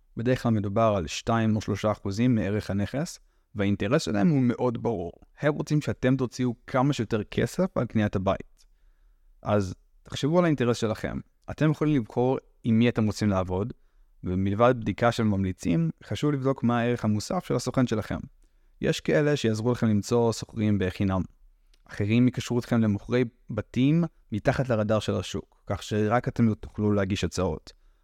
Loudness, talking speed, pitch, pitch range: -26 LUFS, 155 wpm, 110 Hz, 100-125 Hz